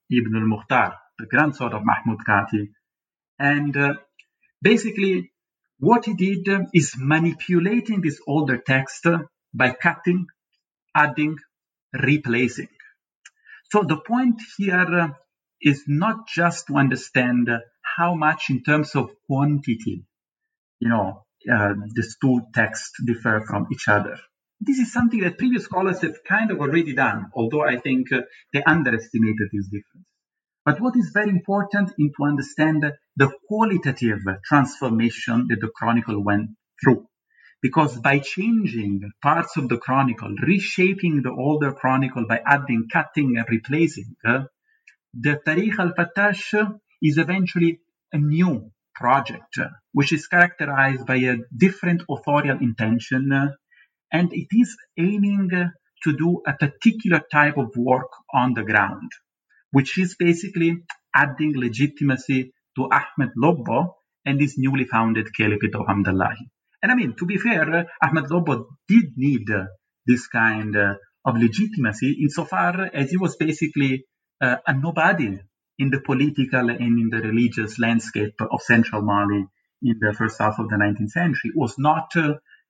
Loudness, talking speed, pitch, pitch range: -21 LUFS, 145 wpm, 140 Hz, 120-175 Hz